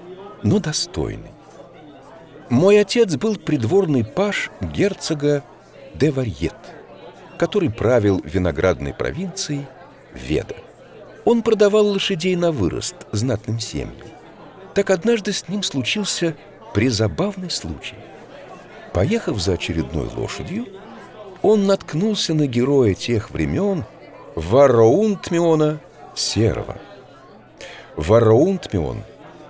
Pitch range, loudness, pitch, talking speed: 130-195 Hz, -19 LUFS, 160 Hz, 85 wpm